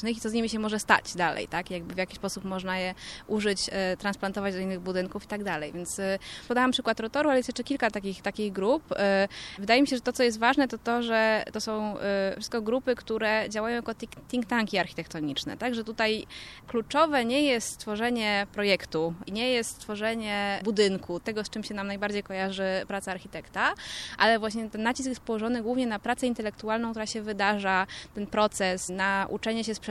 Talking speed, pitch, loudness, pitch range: 200 wpm, 215 Hz, -28 LUFS, 195-230 Hz